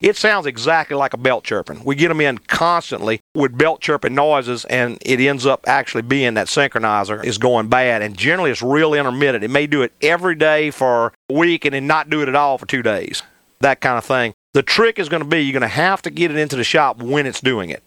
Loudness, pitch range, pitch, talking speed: -17 LUFS, 125-155 Hz, 140 Hz, 250 wpm